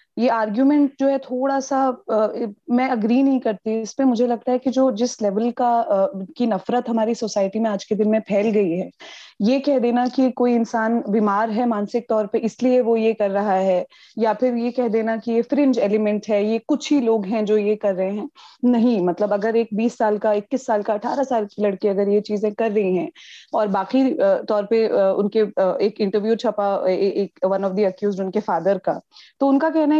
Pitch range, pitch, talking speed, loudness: 205-250 Hz, 225 Hz, 225 wpm, -20 LUFS